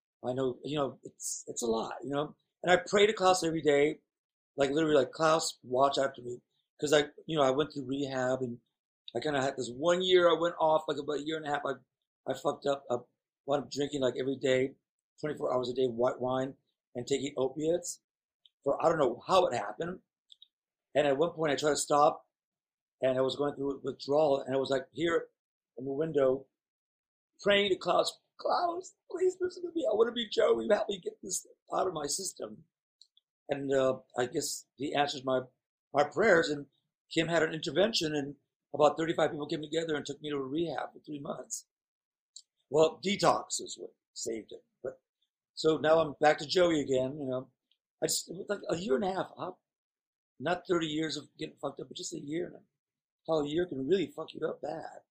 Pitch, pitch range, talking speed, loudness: 150 Hz, 135-170 Hz, 215 wpm, -31 LUFS